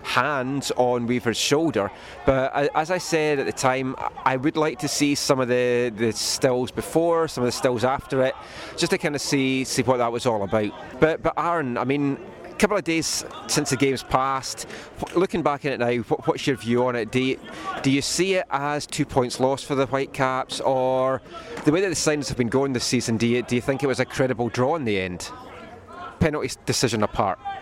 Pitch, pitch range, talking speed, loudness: 130 Hz, 125-145 Hz, 225 wpm, -23 LUFS